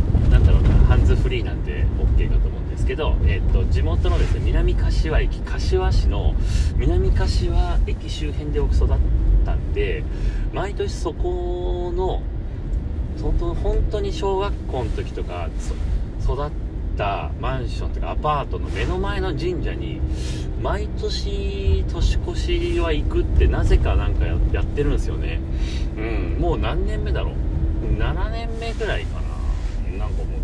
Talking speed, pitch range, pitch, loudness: 235 characters per minute, 70-90 Hz, 80 Hz, -23 LUFS